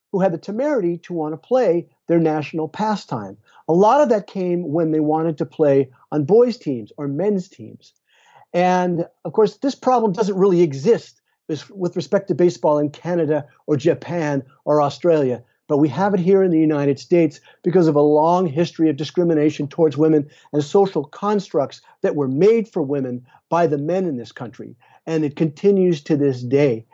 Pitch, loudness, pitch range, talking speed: 165 Hz, -19 LUFS, 150-185 Hz, 185 wpm